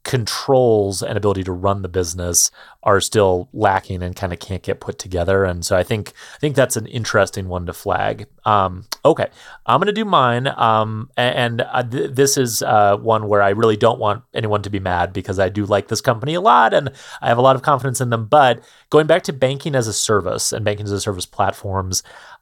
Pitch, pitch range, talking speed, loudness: 105 Hz, 95-125 Hz, 225 wpm, -18 LUFS